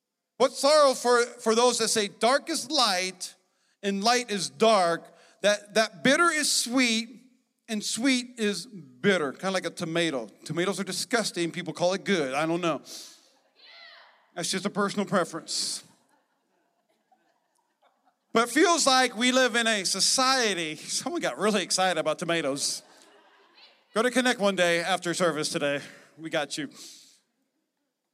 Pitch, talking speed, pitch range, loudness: 205 Hz, 145 wpm, 175-250 Hz, -25 LUFS